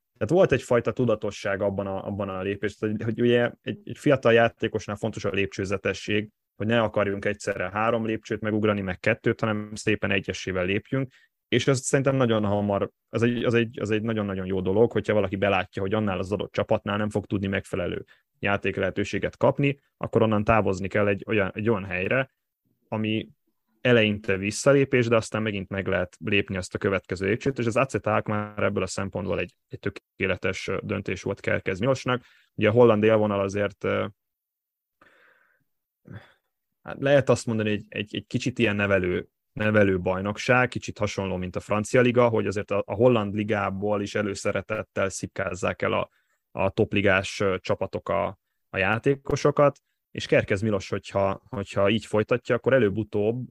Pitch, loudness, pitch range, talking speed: 105 Hz, -25 LUFS, 100-115 Hz, 160 wpm